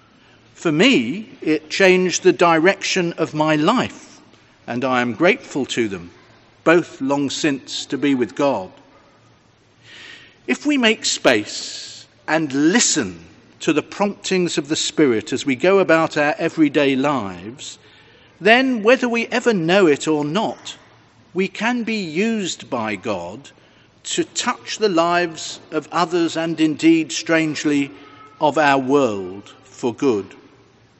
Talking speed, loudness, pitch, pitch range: 135 wpm, -18 LUFS, 160 Hz, 140-200 Hz